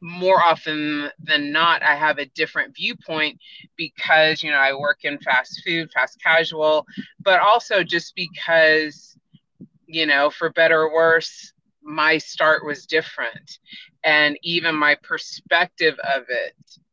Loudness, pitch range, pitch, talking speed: -19 LUFS, 150-175 Hz, 160 Hz, 140 wpm